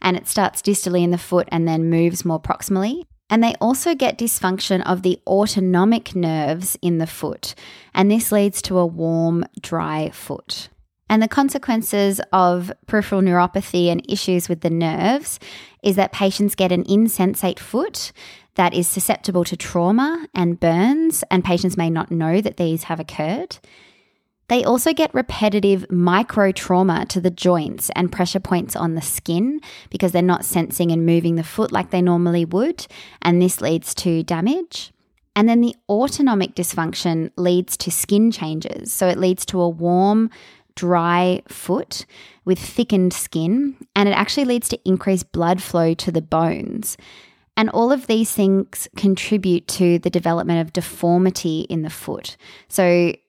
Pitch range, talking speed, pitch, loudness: 175-210 Hz, 160 wpm, 185 Hz, -19 LUFS